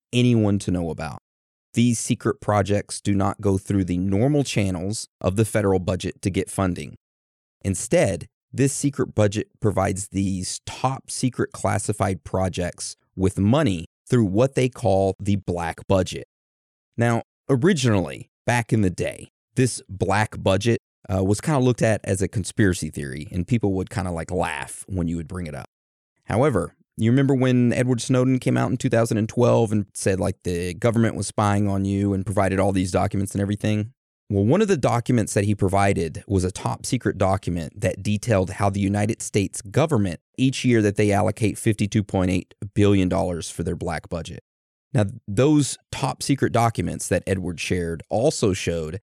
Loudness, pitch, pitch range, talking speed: -23 LUFS, 100 Hz, 95-115 Hz, 170 wpm